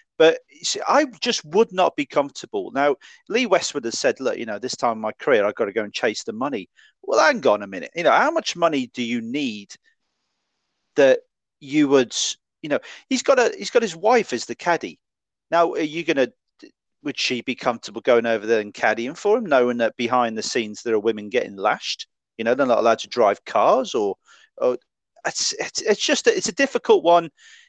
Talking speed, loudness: 220 wpm, -21 LUFS